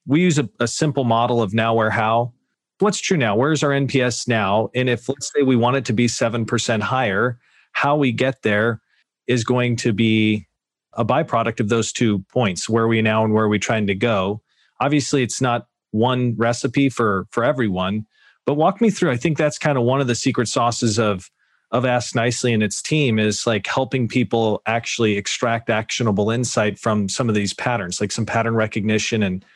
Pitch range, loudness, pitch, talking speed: 110-130 Hz, -20 LUFS, 115 Hz, 205 wpm